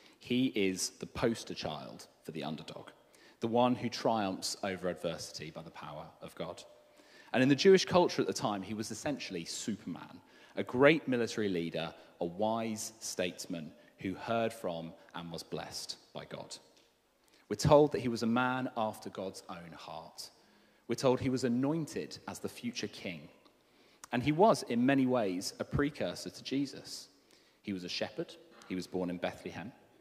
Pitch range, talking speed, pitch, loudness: 100-135 Hz, 170 wpm, 115 Hz, -34 LUFS